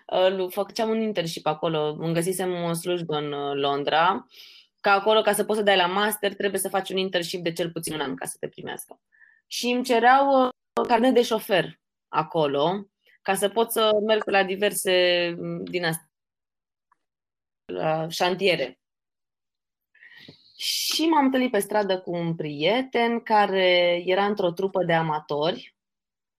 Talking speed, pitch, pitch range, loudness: 150 wpm, 195 Hz, 170-220 Hz, -24 LUFS